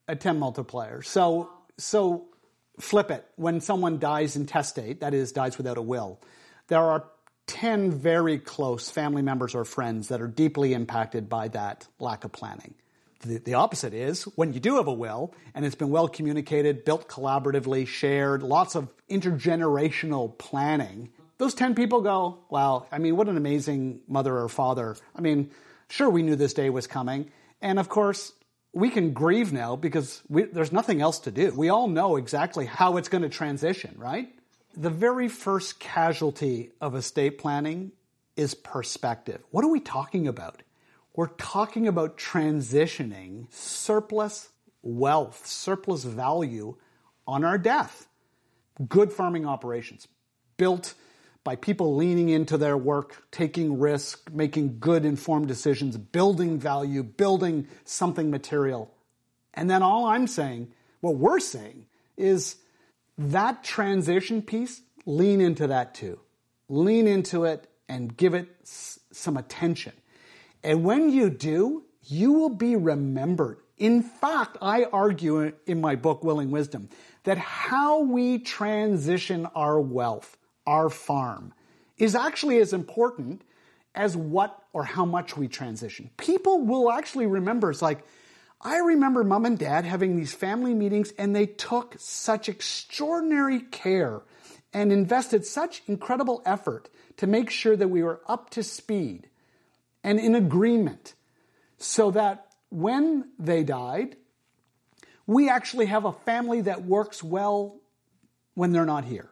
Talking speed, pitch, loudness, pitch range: 145 wpm, 165 Hz, -26 LUFS, 140-205 Hz